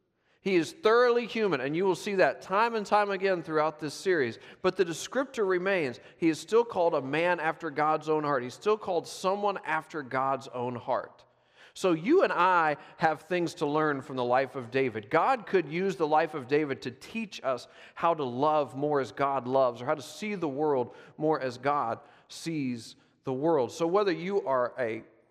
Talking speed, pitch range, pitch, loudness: 200 wpm, 140-190 Hz, 155 Hz, -29 LUFS